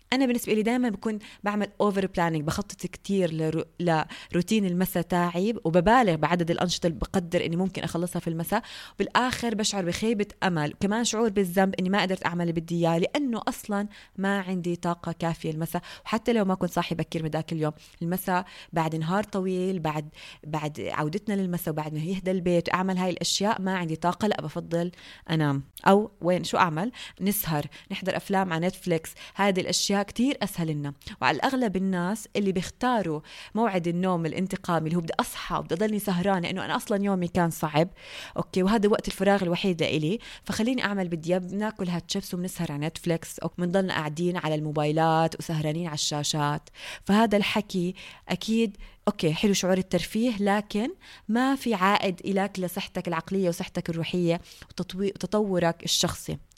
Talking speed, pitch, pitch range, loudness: 160 wpm, 185 Hz, 170-205 Hz, -27 LUFS